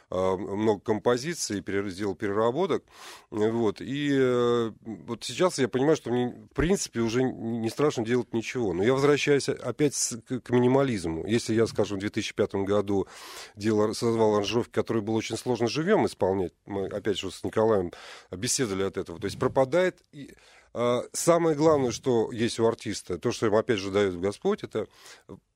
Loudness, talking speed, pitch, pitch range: -27 LUFS, 155 wpm, 115 Hz, 105-130 Hz